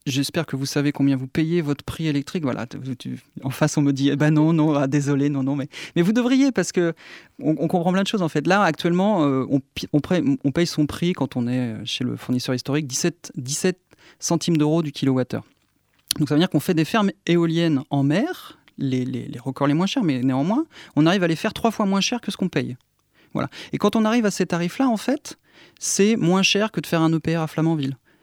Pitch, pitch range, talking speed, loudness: 155 Hz, 140-180 Hz, 235 wpm, -22 LUFS